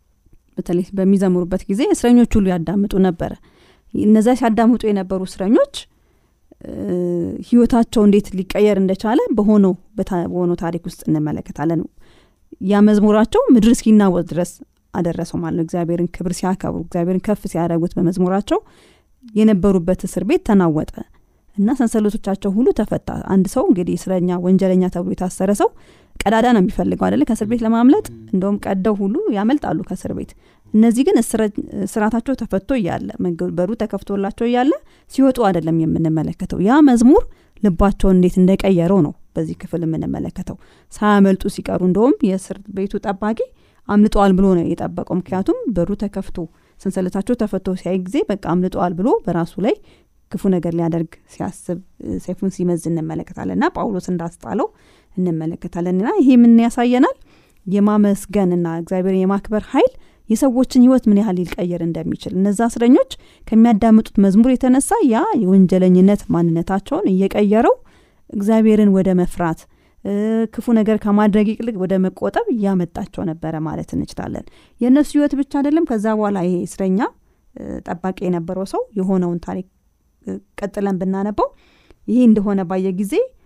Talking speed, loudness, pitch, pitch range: 120 wpm, -17 LUFS, 195 Hz, 180-225 Hz